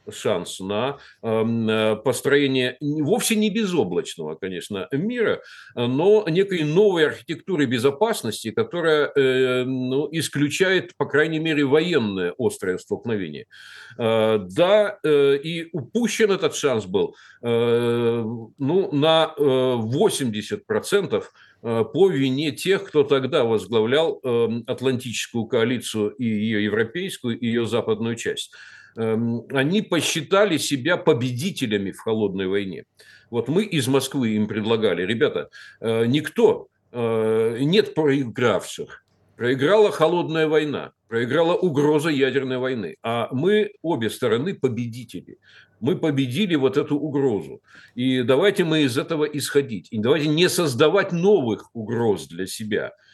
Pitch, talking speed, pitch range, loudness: 140 Hz, 105 wpm, 115-165 Hz, -22 LUFS